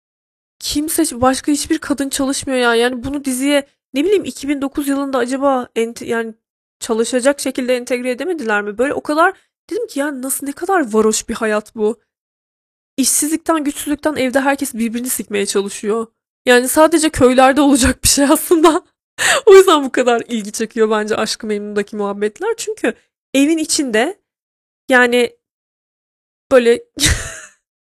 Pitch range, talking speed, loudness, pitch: 230-295 Hz, 140 wpm, -15 LUFS, 265 Hz